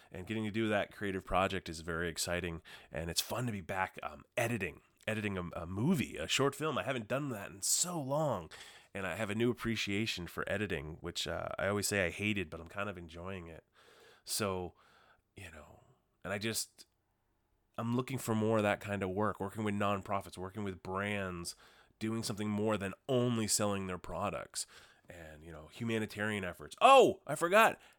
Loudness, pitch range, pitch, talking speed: -35 LUFS, 90-110 Hz, 100 Hz, 195 wpm